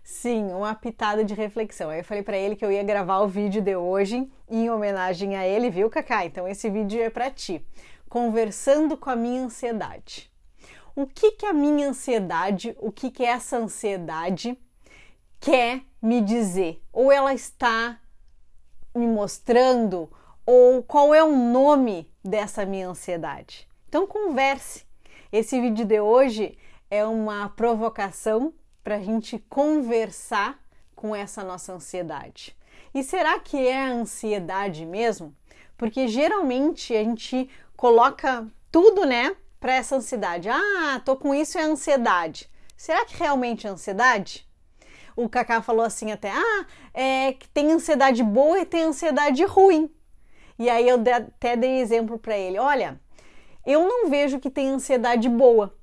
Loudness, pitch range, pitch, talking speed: -23 LUFS, 210-275 Hz, 235 Hz, 145 wpm